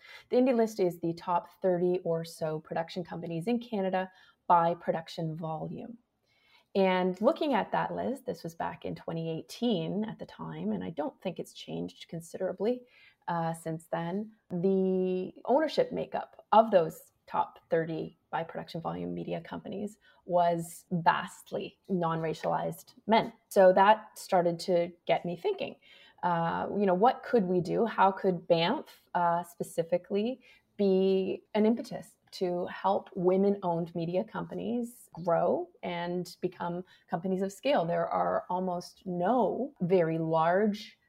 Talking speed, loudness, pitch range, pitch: 140 wpm, -30 LUFS, 170-215 Hz, 185 Hz